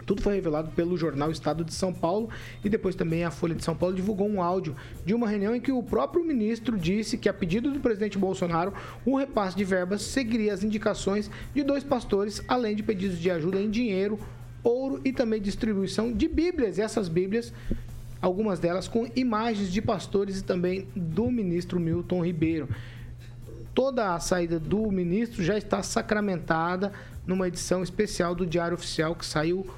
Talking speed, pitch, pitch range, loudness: 180 wpm, 195 Hz, 175-220 Hz, -28 LUFS